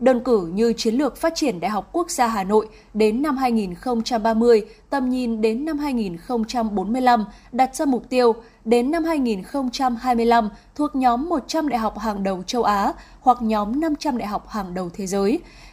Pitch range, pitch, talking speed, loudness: 215-260 Hz, 235 Hz, 175 wpm, -21 LUFS